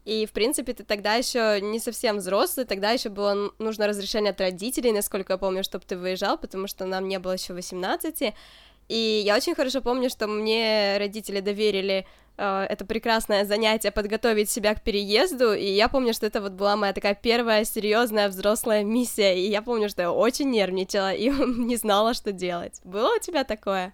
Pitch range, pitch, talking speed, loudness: 200-230 Hz, 210 Hz, 190 wpm, -25 LUFS